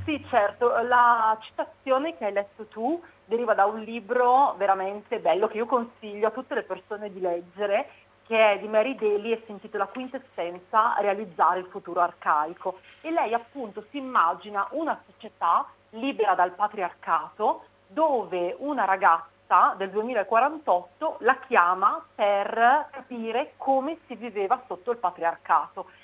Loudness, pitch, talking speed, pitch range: -25 LUFS, 220 Hz, 140 wpm, 195-250 Hz